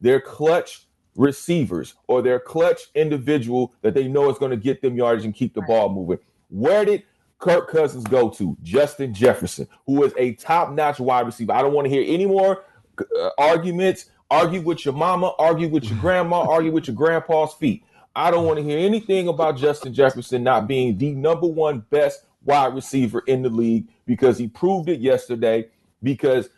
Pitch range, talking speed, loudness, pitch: 125-175 Hz, 185 wpm, -20 LUFS, 145 Hz